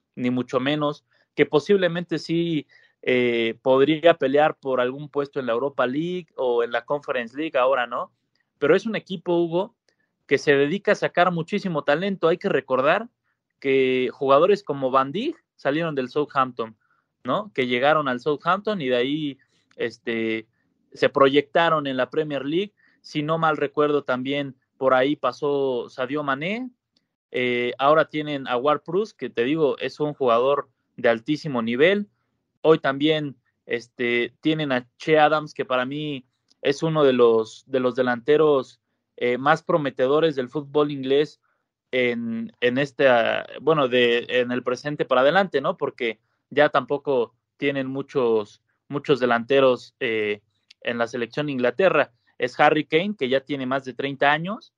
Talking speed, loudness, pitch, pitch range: 155 wpm, -23 LUFS, 140 Hz, 125-155 Hz